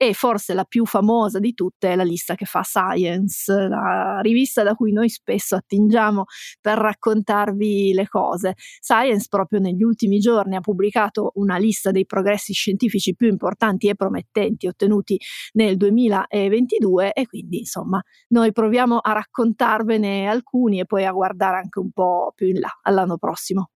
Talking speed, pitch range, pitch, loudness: 160 wpm, 190-220 Hz, 205 Hz, -20 LUFS